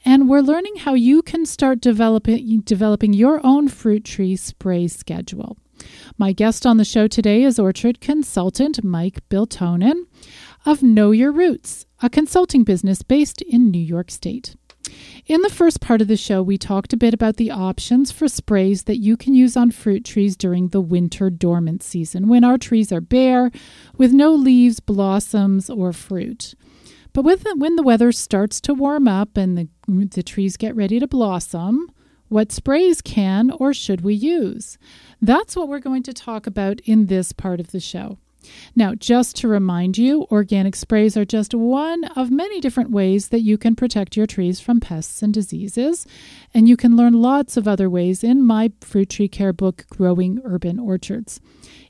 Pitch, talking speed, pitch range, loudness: 225 Hz, 180 wpm, 195-255 Hz, -17 LUFS